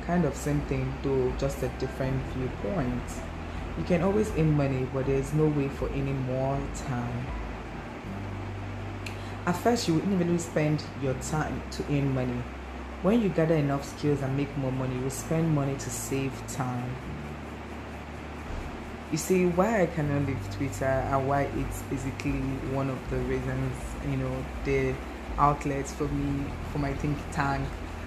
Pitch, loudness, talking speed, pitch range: 135 Hz, -30 LUFS, 160 wpm, 115-145 Hz